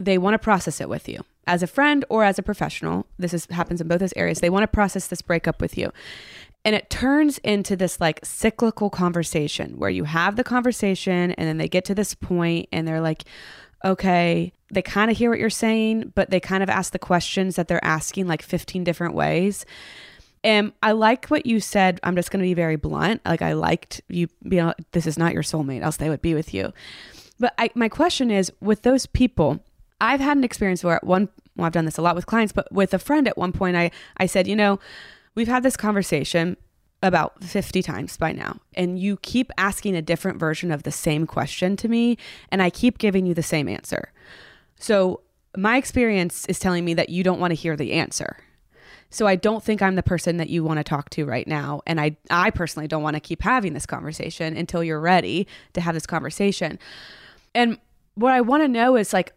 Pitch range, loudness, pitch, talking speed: 165-210 Hz, -22 LUFS, 185 Hz, 225 wpm